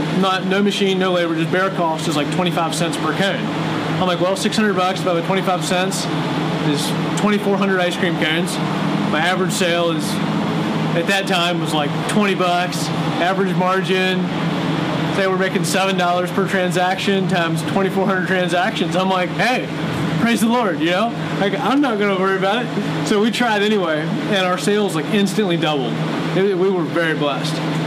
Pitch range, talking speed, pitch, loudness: 160-195 Hz, 170 wpm, 180 Hz, -18 LUFS